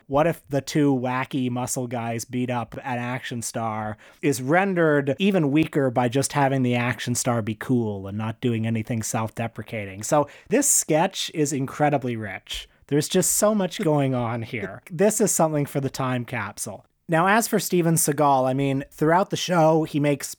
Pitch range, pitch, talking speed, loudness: 120-155 Hz, 135 Hz, 180 wpm, -23 LUFS